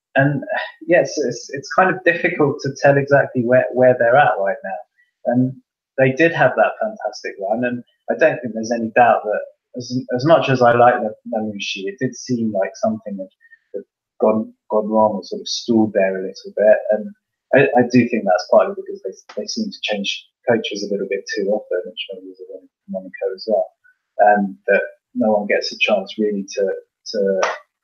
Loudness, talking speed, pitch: -18 LUFS, 205 wpm, 130 Hz